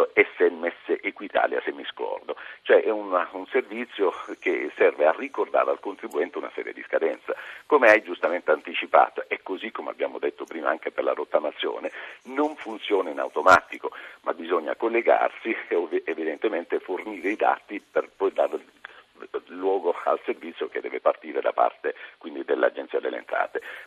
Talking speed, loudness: 155 wpm, -25 LUFS